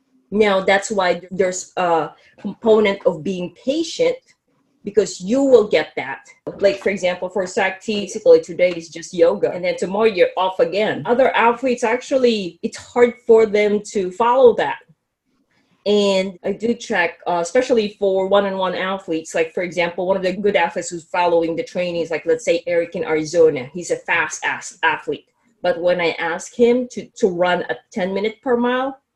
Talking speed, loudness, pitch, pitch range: 180 wpm, -18 LUFS, 205 Hz, 180-245 Hz